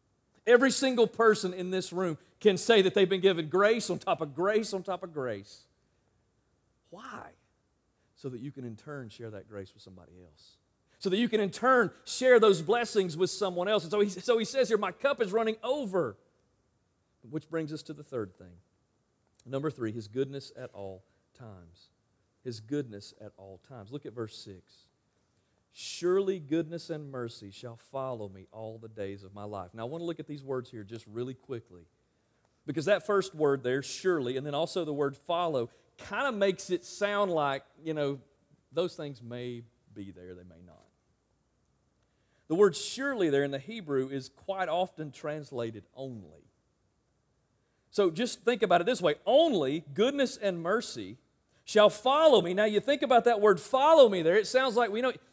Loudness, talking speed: -29 LUFS, 190 wpm